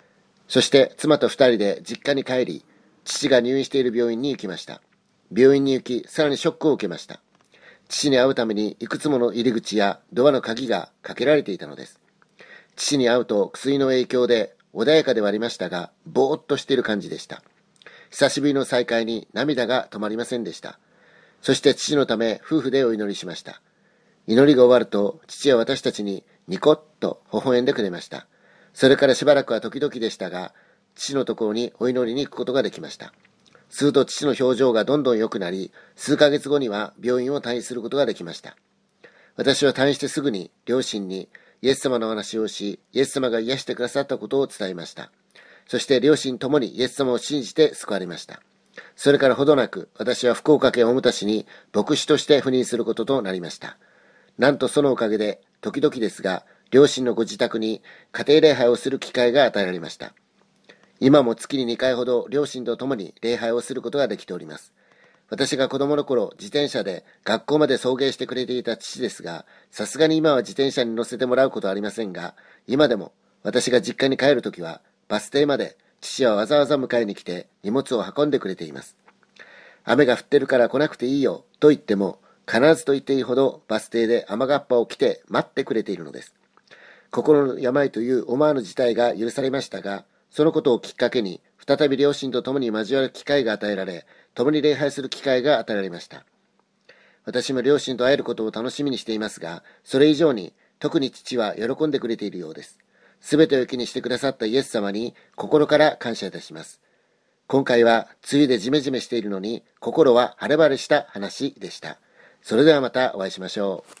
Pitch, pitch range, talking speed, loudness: 125 Hz, 115-140 Hz, 385 characters per minute, -21 LUFS